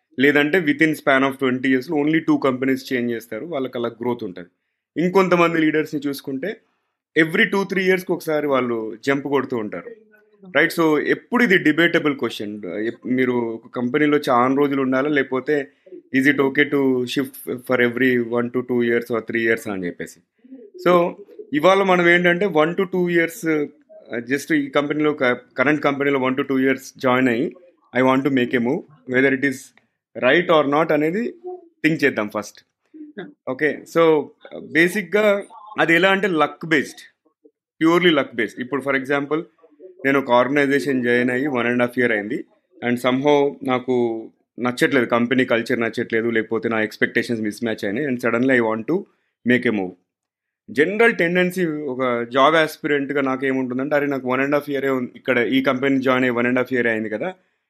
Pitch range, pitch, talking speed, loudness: 125-160 Hz, 135 Hz, 165 wpm, -19 LUFS